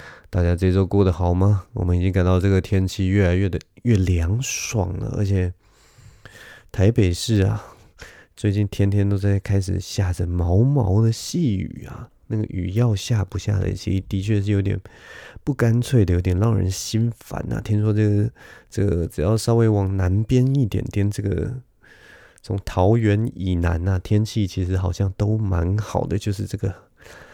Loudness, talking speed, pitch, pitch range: -21 LUFS, 250 characters per minute, 100 Hz, 95-110 Hz